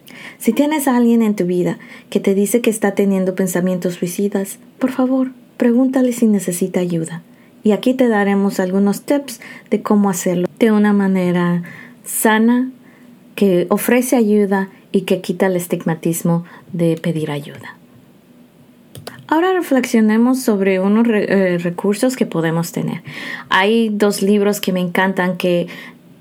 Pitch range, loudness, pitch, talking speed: 185-240 Hz, -16 LUFS, 205 Hz, 140 wpm